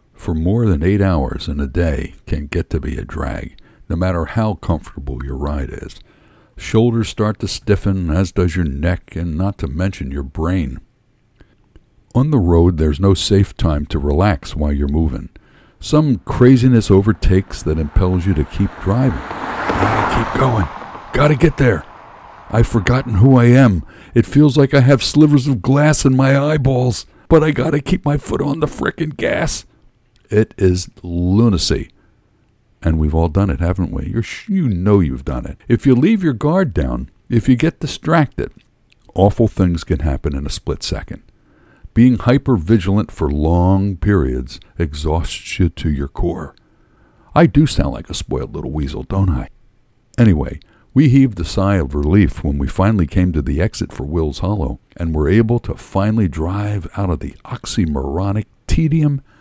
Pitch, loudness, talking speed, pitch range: 95 Hz, -16 LUFS, 175 wpm, 80-120 Hz